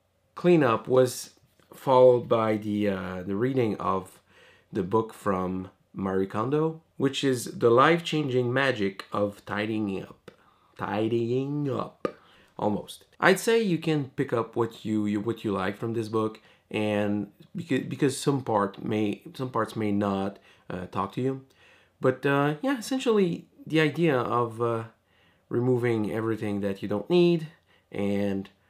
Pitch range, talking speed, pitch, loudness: 105-140 Hz, 145 wpm, 115 Hz, -27 LUFS